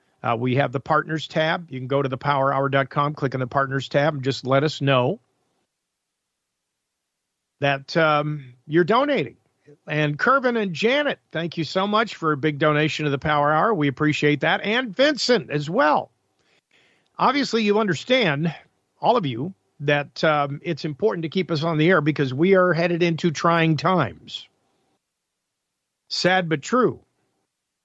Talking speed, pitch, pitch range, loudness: 160 wpm, 155 Hz, 140-175 Hz, -21 LUFS